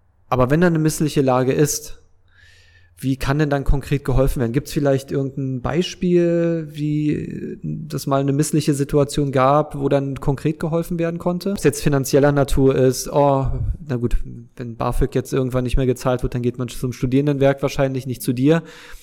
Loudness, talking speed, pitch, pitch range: -20 LUFS, 180 wpm, 140 Hz, 130-150 Hz